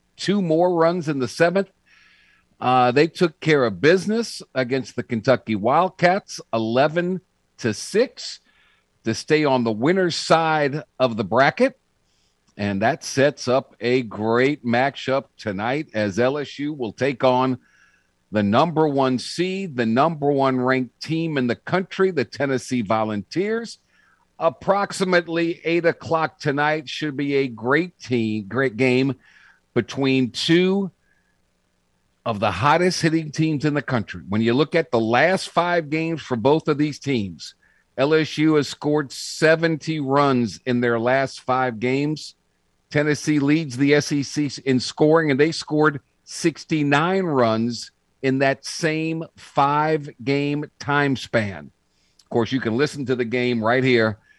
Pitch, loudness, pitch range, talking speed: 140 Hz, -21 LUFS, 120-160 Hz, 140 wpm